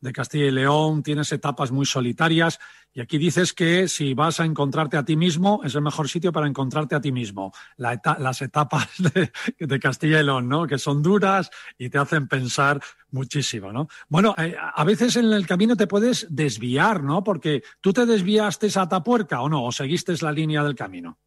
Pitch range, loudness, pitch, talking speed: 140-185 Hz, -22 LUFS, 155 Hz, 205 wpm